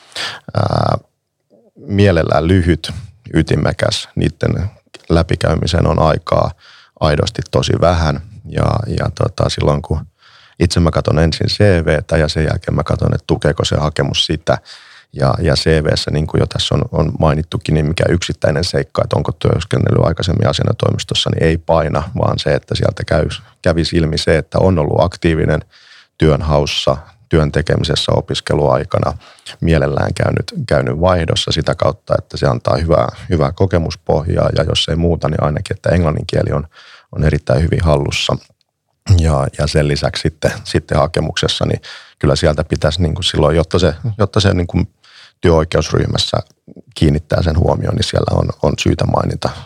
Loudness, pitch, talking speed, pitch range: -15 LUFS, 80 Hz, 150 wpm, 75-90 Hz